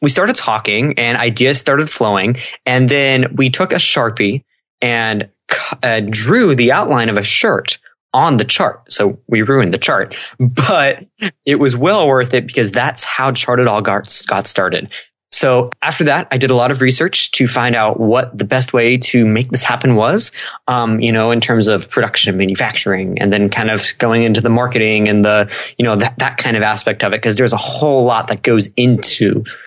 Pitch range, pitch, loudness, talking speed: 110-130 Hz, 120 Hz, -13 LUFS, 200 wpm